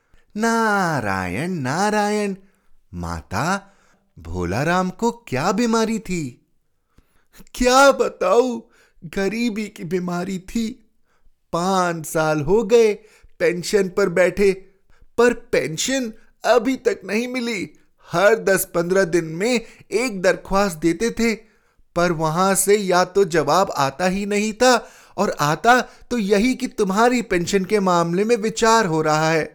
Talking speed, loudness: 125 wpm, -20 LUFS